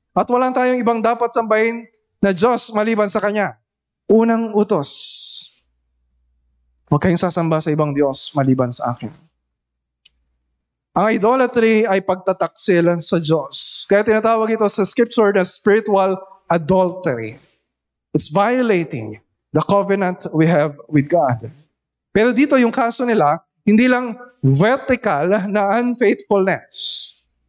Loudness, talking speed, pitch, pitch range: -17 LUFS, 120 wpm, 190 Hz, 145-220 Hz